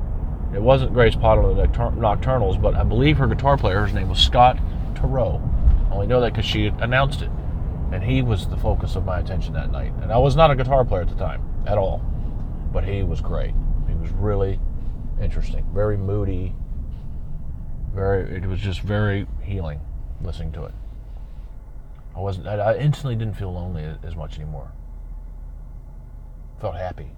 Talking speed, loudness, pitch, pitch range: 175 wpm, -22 LUFS, 95 Hz, 75-105 Hz